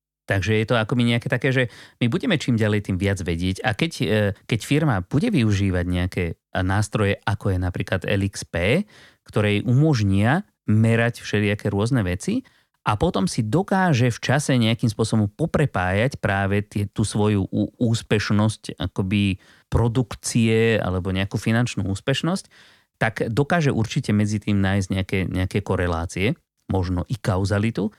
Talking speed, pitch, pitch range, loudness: 140 wpm, 105 Hz, 100-125 Hz, -22 LUFS